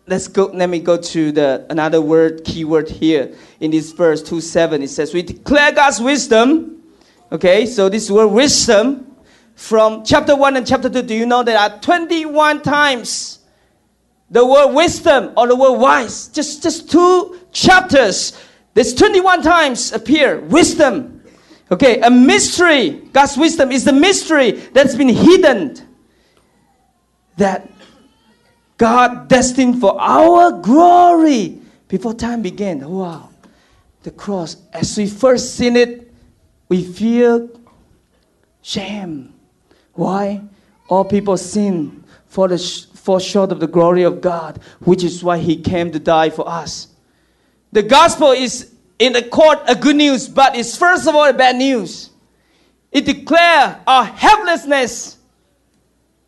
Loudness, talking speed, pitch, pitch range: -13 LUFS, 140 wpm, 240 Hz, 190-290 Hz